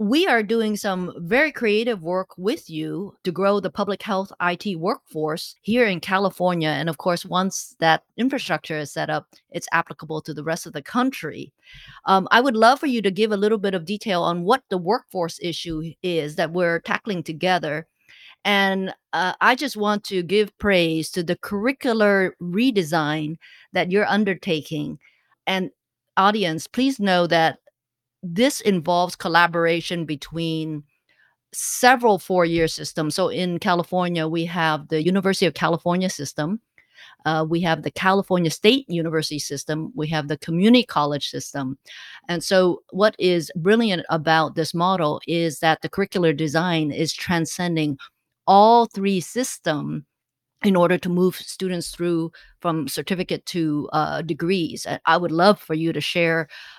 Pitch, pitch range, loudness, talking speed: 175 Hz, 160-200 Hz, -22 LUFS, 155 wpm